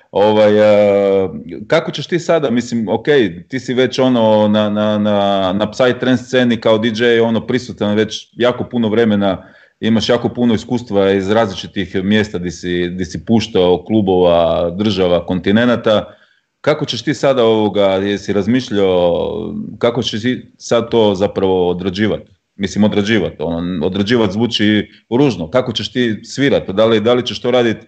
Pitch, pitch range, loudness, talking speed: 110 Hz, 100-120 Hz, -15 LUFS, 155 wpm